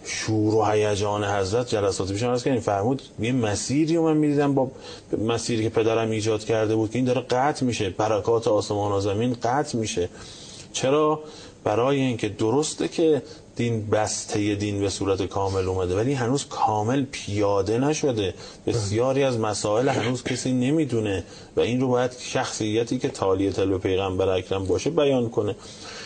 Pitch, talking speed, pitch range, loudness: 115 Hz, 160 wpm, 105-130 Hz, -24 LUFS